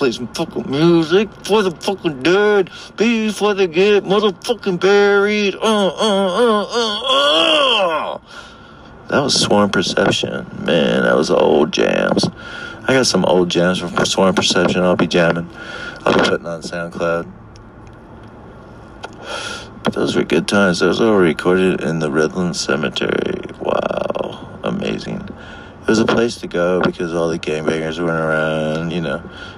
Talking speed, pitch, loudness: 145 wpm, 115 Hz, -16 LUFS